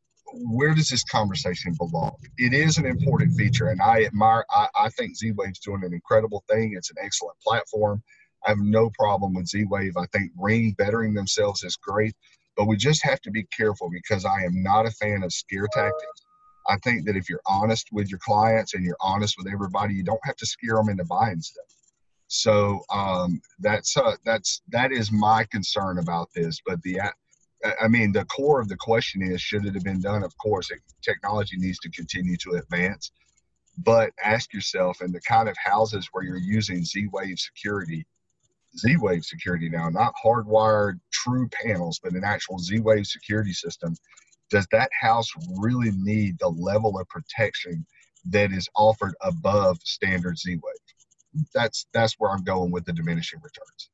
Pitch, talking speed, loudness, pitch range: 105 Hz, 180 wpm, -24 LUFS, 90-115 Hz